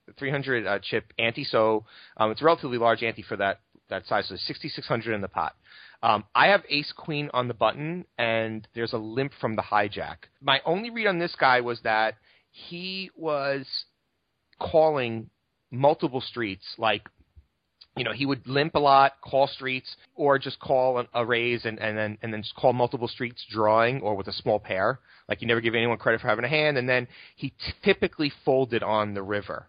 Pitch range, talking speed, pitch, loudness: 110-140 Hz, 190 wpm, 120 Hz, -26 LUFS